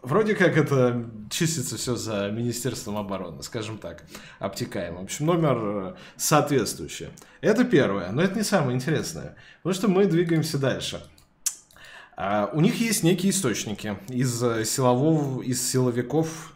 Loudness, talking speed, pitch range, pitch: -25 LUFS, 130 wpm, 115-165 Hz, 130 Hz